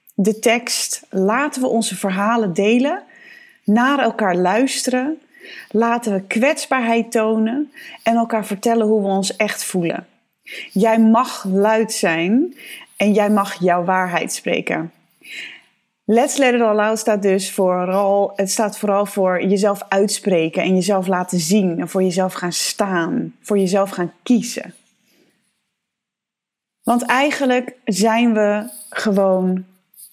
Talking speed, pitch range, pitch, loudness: 125 wpm, 195-235 Hz, 210 Hz, -18 LUFS